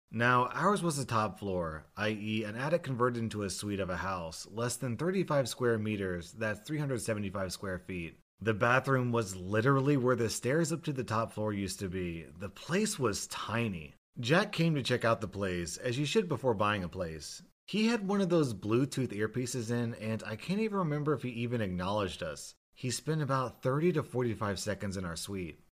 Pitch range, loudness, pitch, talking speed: 100-135 Hz, -33 LUFS, 115 Hz, 200 wpm